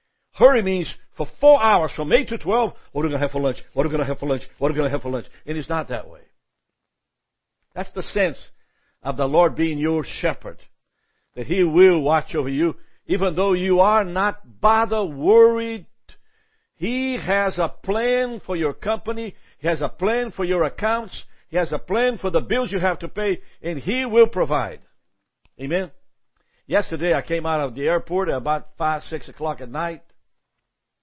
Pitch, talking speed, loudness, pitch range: 175 Hz, 200 wpm, -21 LUFS, 150-220 Hz